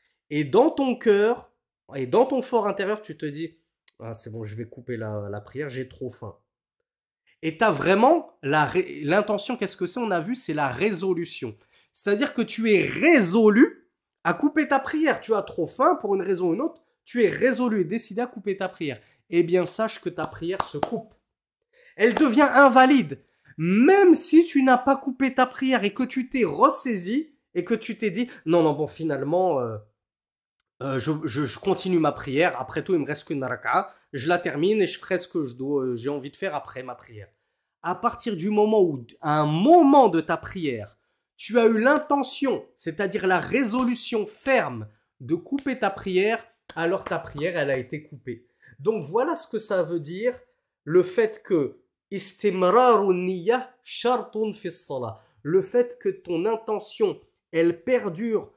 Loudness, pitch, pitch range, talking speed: -23 LUFS, 200 Hz, 160-250 Hz, 180 wpm